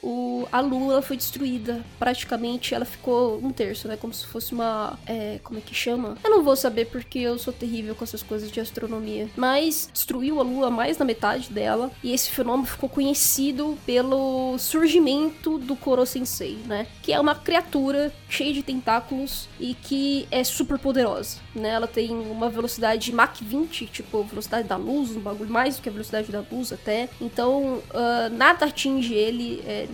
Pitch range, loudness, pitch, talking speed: 225-270 Hz, -24 LUFS, 245 Hz, 180 wpm